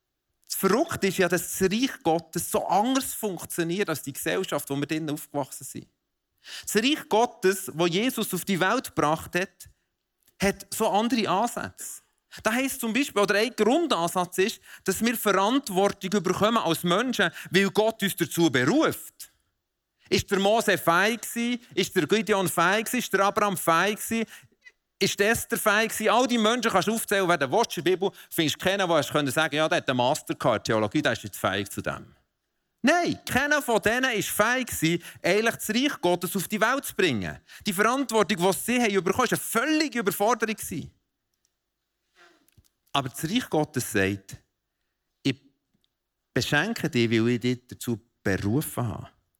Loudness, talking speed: -25 LUFS, 165 wpm